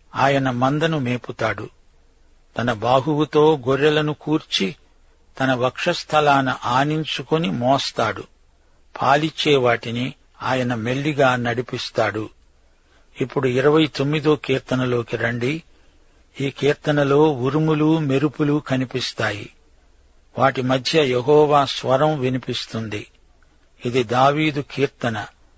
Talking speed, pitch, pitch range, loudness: 75 wpm, 130 Hz, 110-150 Hz, -20 LUFS